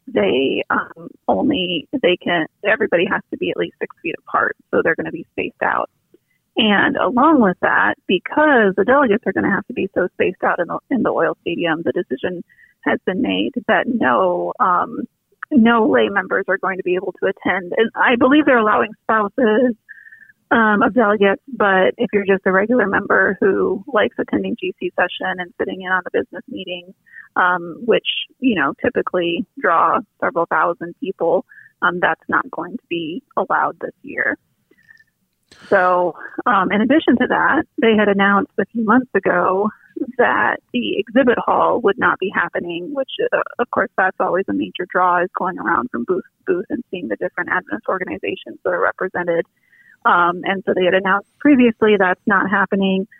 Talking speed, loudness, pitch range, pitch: 185 wpm, -18 LUFS, 190-290 Hz, 215 Hz